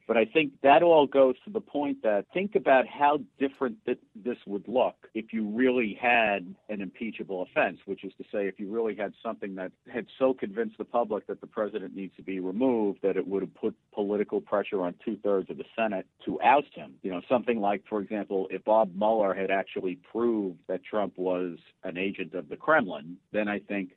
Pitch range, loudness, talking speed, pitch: 95-125 Hz, -28 LUFS, 215 wpm, 105 Hz